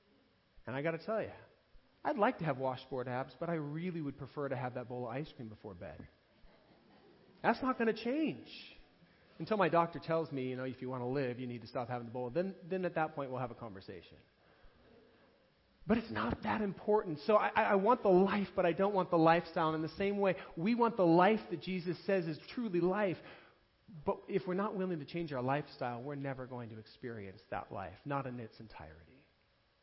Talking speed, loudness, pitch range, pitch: 225 wpm, -35 LUFS, 130-190 Hz, 160 Hz